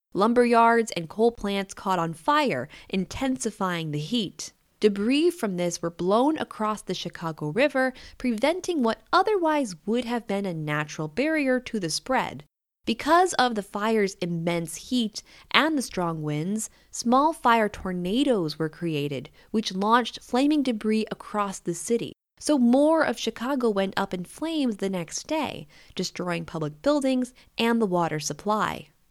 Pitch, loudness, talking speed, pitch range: 220 Hz, -25 LUFS, 150 wpm, 175-255 Hz